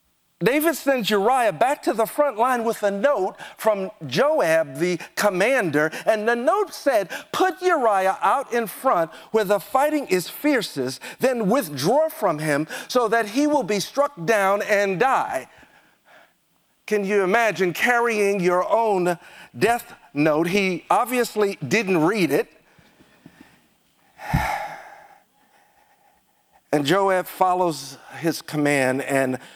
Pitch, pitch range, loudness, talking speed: 210 Hz, 180-275 Hz, -21 LUFS, 125 wpm